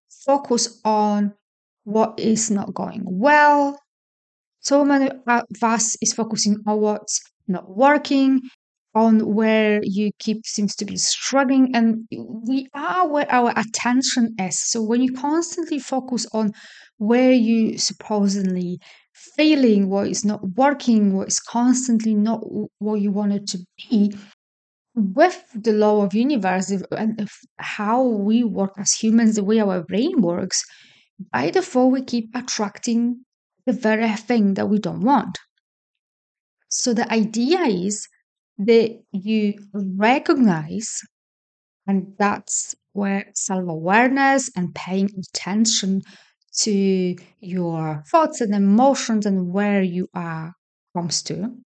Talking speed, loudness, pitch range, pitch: 125 wpm, -20 LUFS, 200-245 Hz, 220 Hz